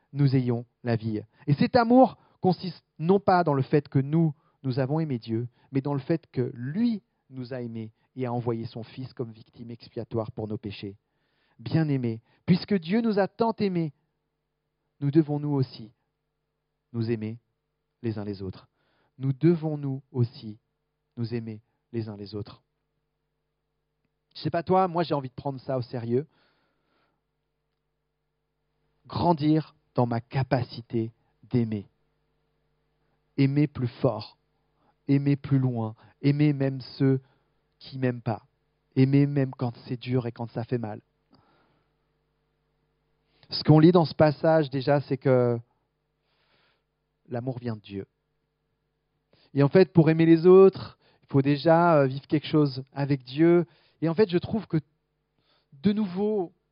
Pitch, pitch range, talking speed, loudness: 140 Hz, 125-155 Hz, 150 wpm, -26 LUFS